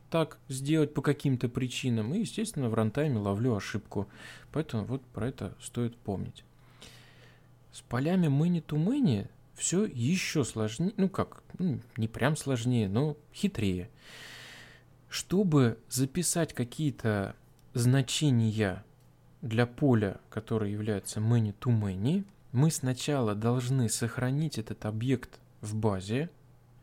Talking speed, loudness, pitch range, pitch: 105 wpm, -31 LUFS, 110-145 Hz, 125 Hz